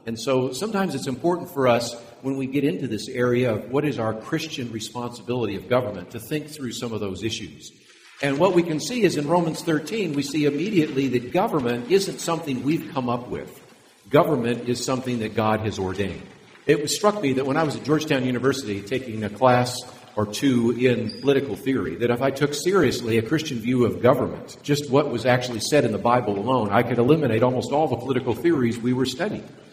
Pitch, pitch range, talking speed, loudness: 125 Hz, 120-145 Hz, 210 wpm, -23 LUFS